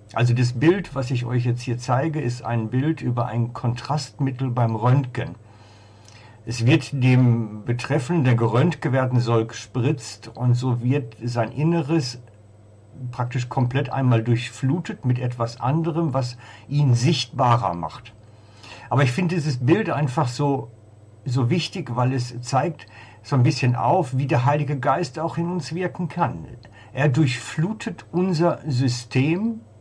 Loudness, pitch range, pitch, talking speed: -22 LUFS, 115-150 Hz, 125 Hz, 145 wpm